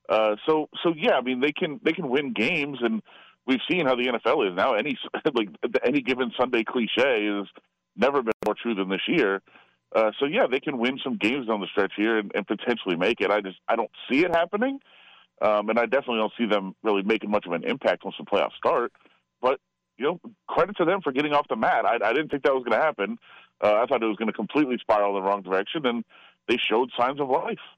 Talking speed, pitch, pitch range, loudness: 245 wpm, 115 Hz, 105-145 Hz, -25 LUFS